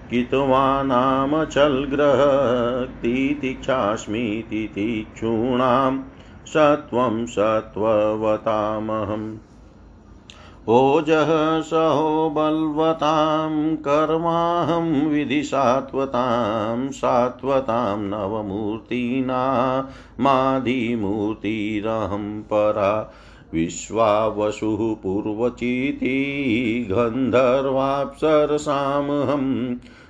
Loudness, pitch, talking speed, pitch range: -21 LUFS, 130 Hz, 35 wpm, 110-145 Hz